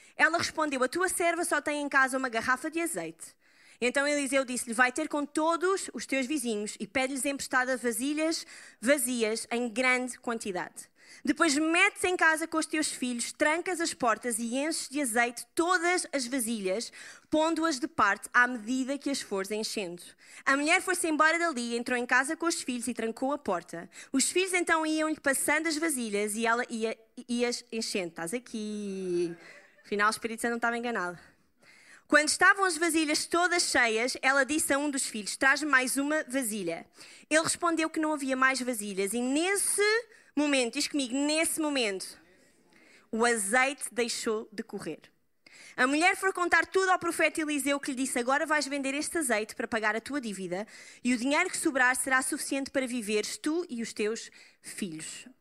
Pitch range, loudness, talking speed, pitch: 235-315 Hz, -28 LUFS, 175 wpm, 270 Hz